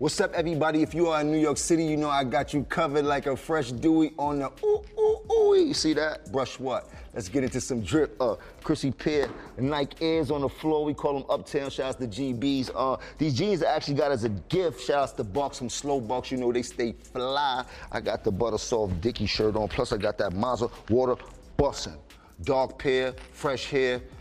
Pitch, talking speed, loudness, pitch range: 140 Hz, 225 wpm, -27 LUFS, 125-155 Hz